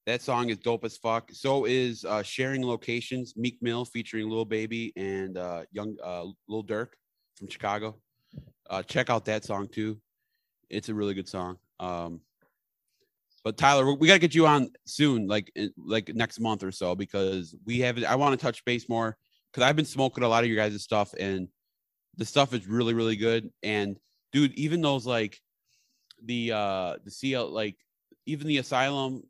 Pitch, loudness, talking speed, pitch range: 115 Hz, -28 LUFS, 180 wpm, 105-125 Hz